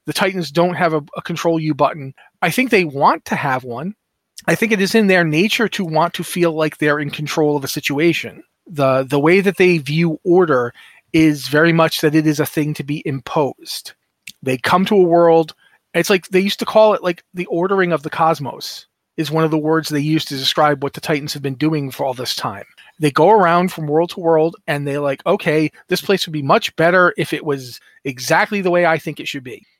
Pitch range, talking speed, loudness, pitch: 150-180 Hz, 235 wpm, -16 LUFS, 160 Hz